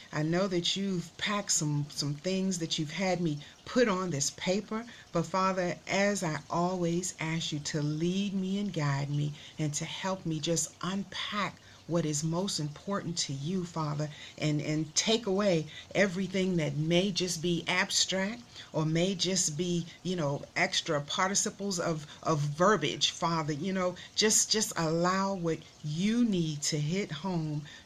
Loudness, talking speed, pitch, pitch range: -31 LUFS, 160 wpm, 170 Hz, 155-190 Hz